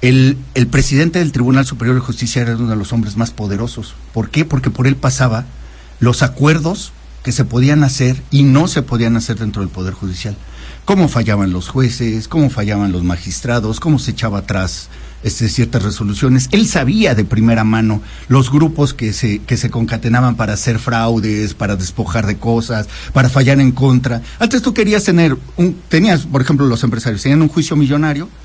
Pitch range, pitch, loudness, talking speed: 110-135 Hz, 120 Hz, -14 LUFS, 185 wpm